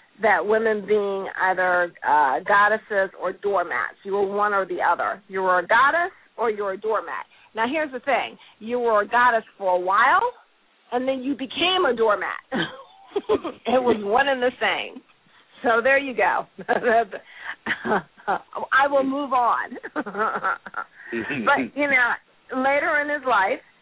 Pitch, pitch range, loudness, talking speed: 230 Hz, 200-275 Hz, -22 LUFS, 150 wpm